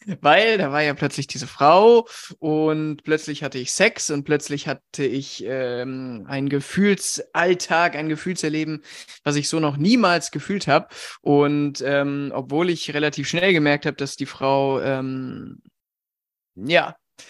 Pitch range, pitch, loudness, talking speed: 140-165 Hz, 145 Hz, -21 LUFS, 140 wpm